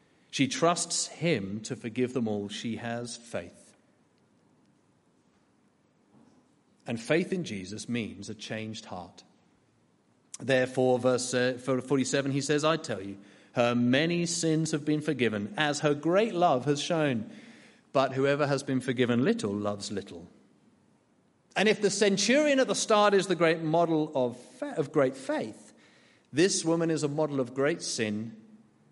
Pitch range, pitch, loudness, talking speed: 115-165 Hz, 135 Hz, -28 LUFS, 140 wpm